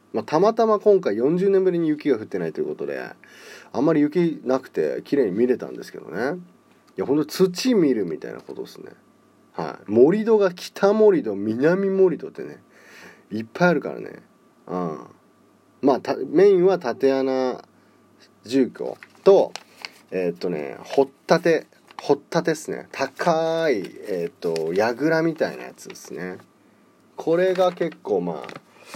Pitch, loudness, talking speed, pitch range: 175 Hz, -22 LUFS, 295 characters per minute, 145-215 Hz